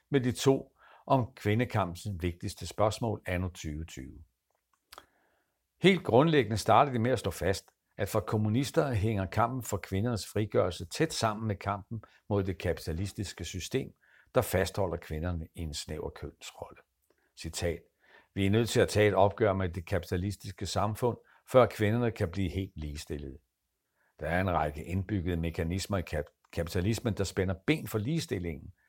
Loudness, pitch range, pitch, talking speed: -31 LUFS, 90-110 Hz, 100 Hz, 150 wpm